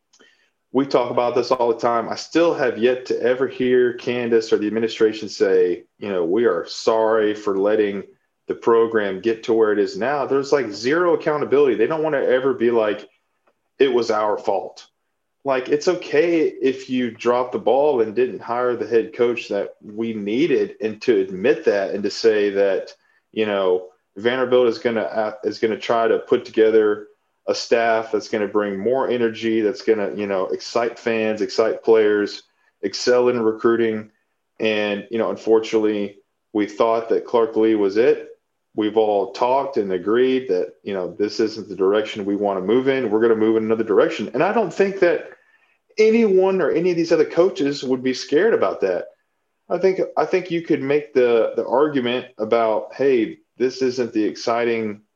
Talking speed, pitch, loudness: 190 wpm, 130 Hz, -20 LUFS